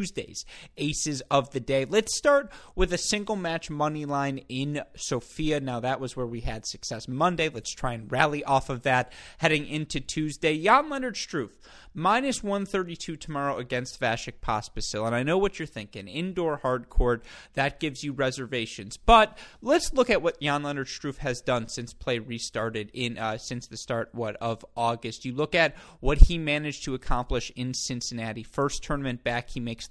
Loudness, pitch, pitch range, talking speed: -28 LUFS, 135 Hz, 120-155 Hz, 185 wpm